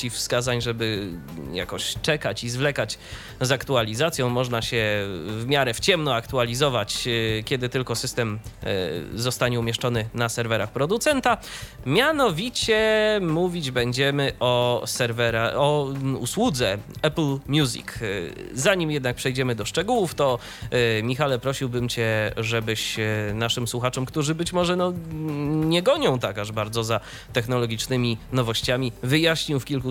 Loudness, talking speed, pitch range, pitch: -24 LUFS, 120 wpm, 115-145 Hz, 125 Hz